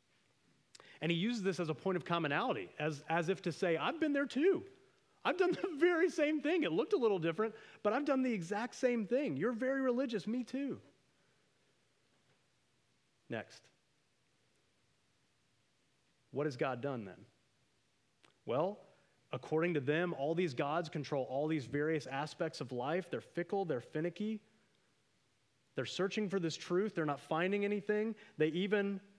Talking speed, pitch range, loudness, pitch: 155 wpm, 155-240 Hz, -37 LUFS, 190 Hz